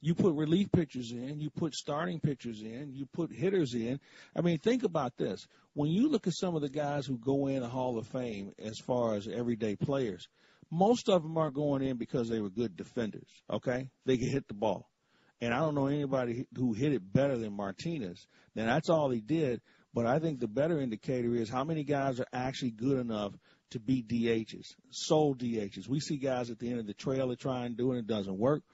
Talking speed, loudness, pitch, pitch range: 220 wpm, -33 LUFS, 130 Hz, 120-150 Hz